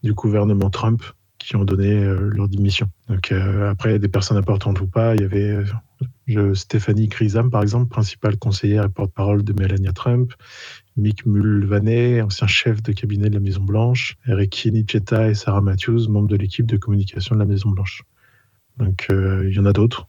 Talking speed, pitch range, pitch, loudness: 195 wpm, 100-115 Hz, 105 Hz, -19 LUFS